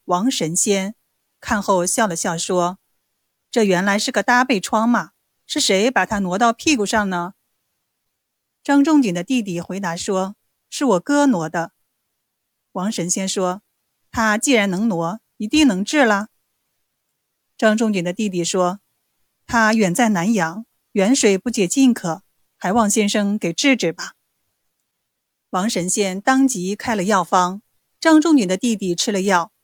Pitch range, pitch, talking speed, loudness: 185-235 Hz, 205 Hz, 200 characters per minute, -18 LUFS